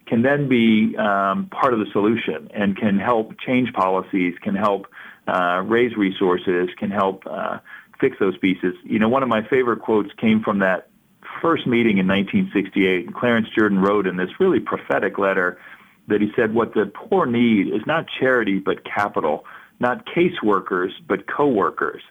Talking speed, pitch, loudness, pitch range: 170 wpm, 100 Hz, -20 LUFS, 95-115 Hz